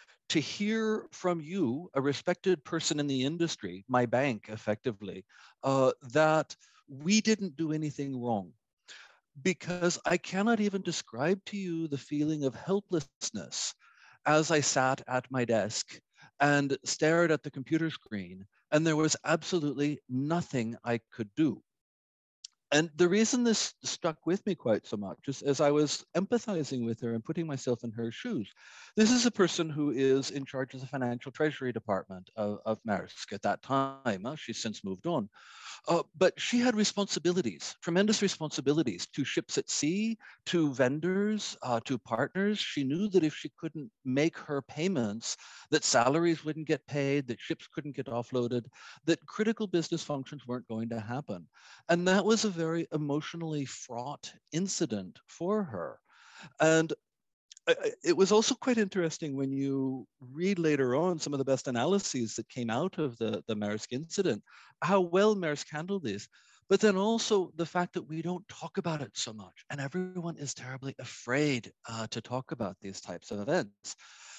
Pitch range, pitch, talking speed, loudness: 125-180 Hz, 150 Hz, 165 wpm, -31 LUFS